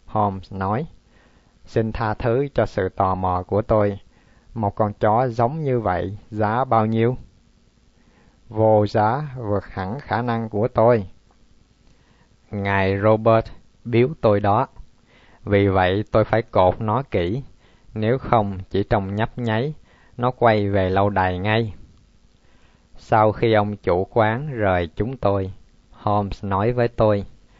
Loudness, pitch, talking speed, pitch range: -21 LUFS, 105 Hz, 140 wpm, 100-115 Hz